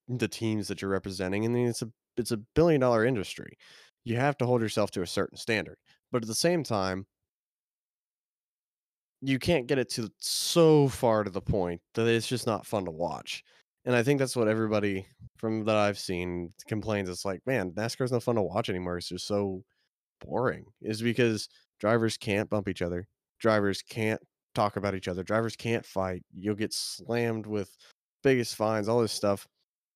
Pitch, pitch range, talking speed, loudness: 110 Hz, 100-120 Hz, 190 wpm, -29 LUFS